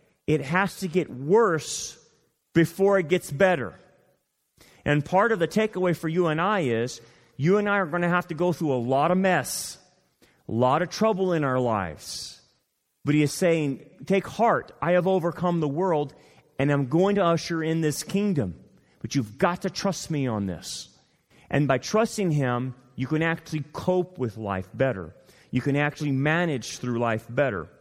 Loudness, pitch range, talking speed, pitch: -25 LUFS, 130-180 Hz, 185 wpm, 155 Hz